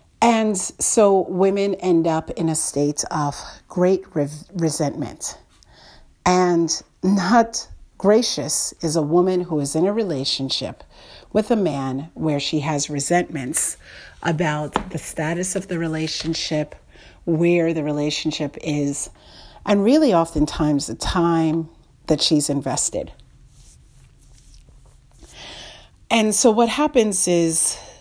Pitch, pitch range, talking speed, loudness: 165 Hz, 150-190 Hz, 115 wpm, -20 LUFS